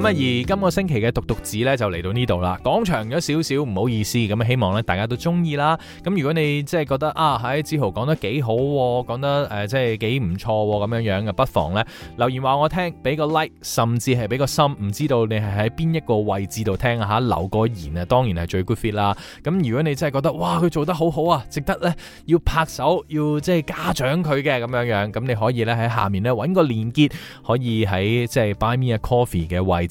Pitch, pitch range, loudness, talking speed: 125 Hz, 110-150 Hz, -21 LUFS, 370 characters per minute